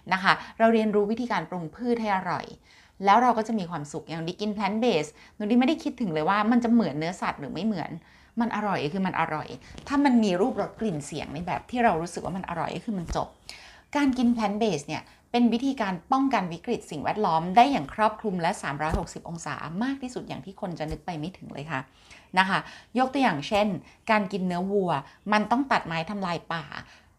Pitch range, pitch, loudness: 165-230 Hz, 200 Hz, -27 LUFS